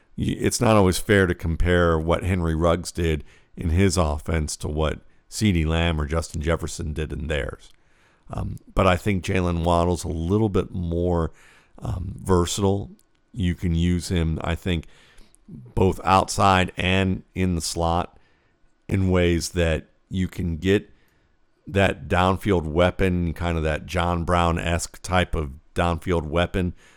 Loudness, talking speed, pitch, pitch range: -23 LUFS, 145 wpm, 85 Hz, 85-95 Hz